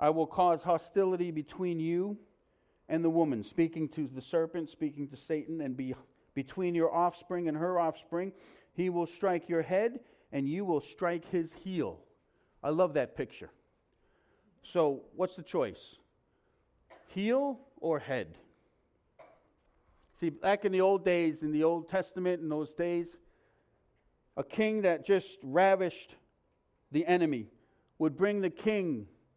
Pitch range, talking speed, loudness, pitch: 160-185 Hz, 145 wpm, -32 LUFS, 170 Hz